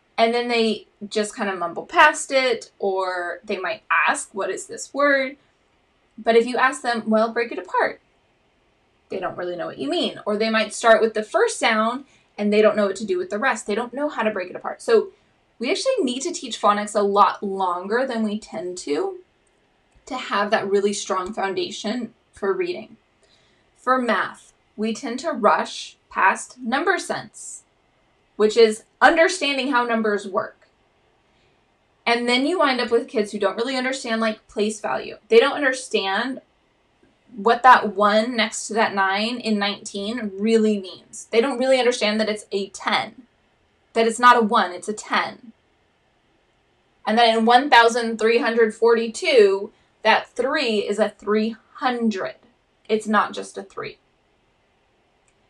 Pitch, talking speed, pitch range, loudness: 225 Hz, 165 wpm, 210-255 Hz, -21 LUFS